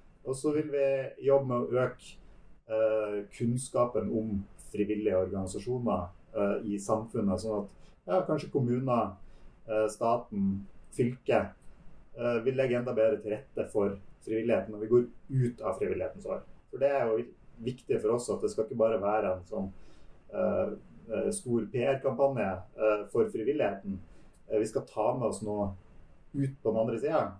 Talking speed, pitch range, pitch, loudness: 160 wpm, 100-125 Hz, 110 Hz, -31 LUFS